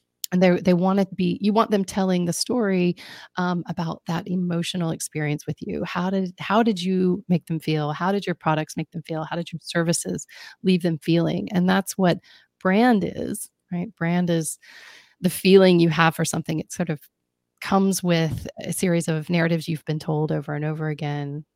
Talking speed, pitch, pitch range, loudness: 200 wpm, 170 Hz, 160-185 Hz, -23 LUFS